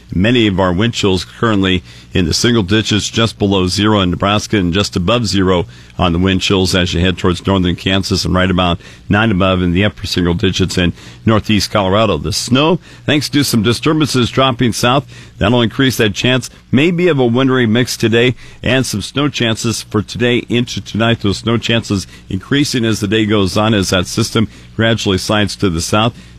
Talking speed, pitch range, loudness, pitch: 195 wpm, 95-115 Hz, -14 LUFS, 105 Hz